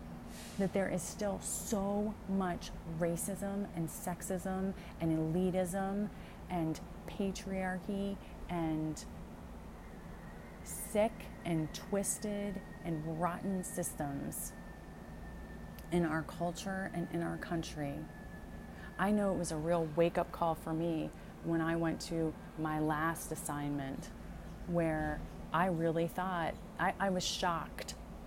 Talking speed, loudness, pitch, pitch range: 115 wpm, -37 LUFS, 175 Hz, 160-195 Hz